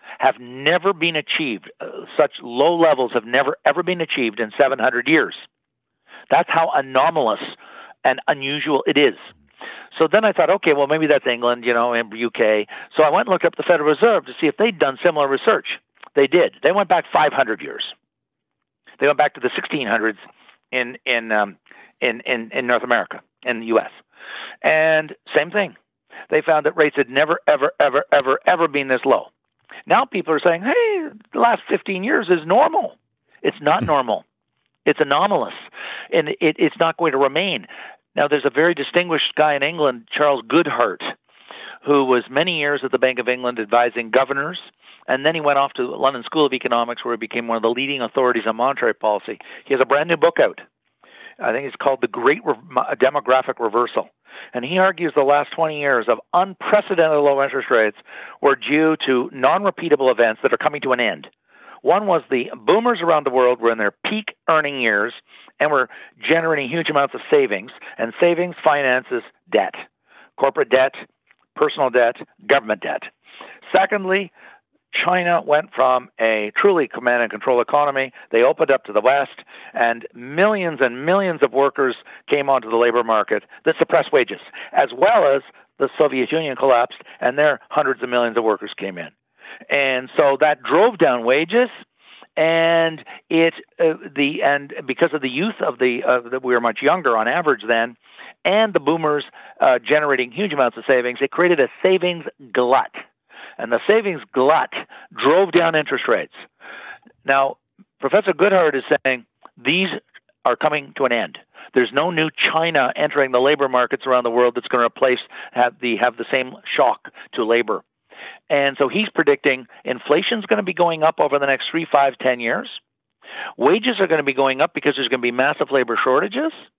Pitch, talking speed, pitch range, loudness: 140 Hz, 185 wpm, 125-170 Hz, -19 LUFS